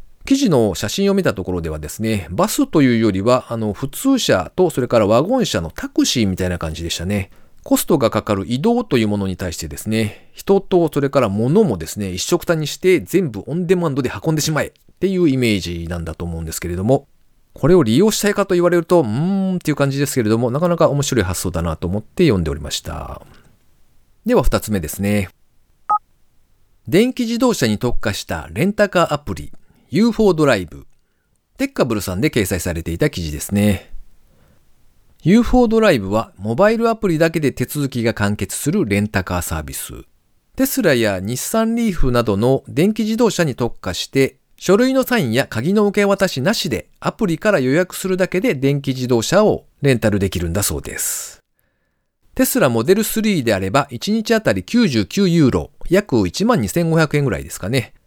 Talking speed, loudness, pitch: 370 characters per minute, -18 LUFS, 135 Hz